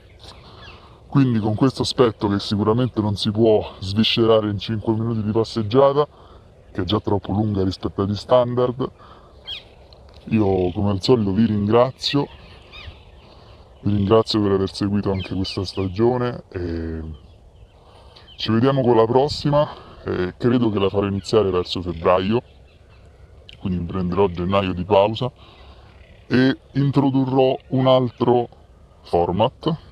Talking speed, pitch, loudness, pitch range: 125 wpm, 105 Hz, -20 LUFS, 95-120 Hz